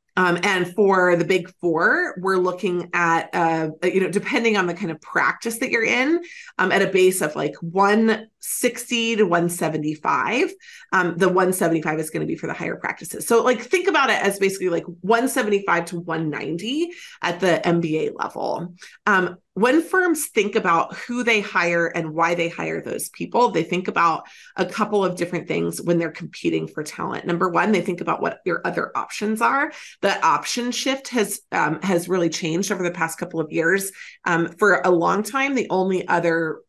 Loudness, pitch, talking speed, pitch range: -21 LUFS, 185 Hz, 190 wpm, 170-225 Hz